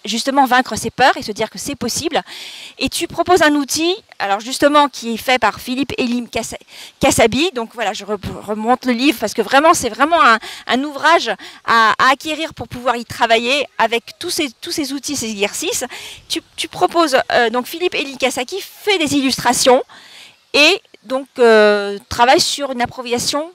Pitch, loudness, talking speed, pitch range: 260 Hz, -16 LUFS, 180 wpm, 230-310 Hz